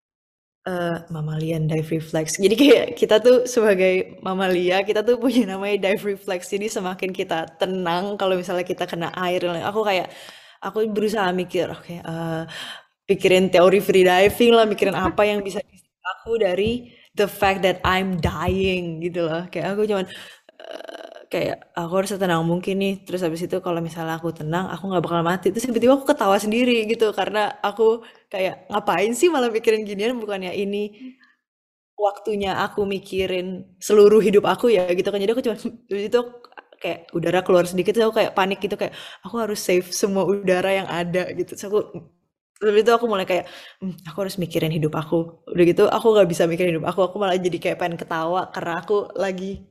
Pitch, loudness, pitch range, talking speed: 190 Hz, -21 LUFS, 180-210 Hz, 180 wpm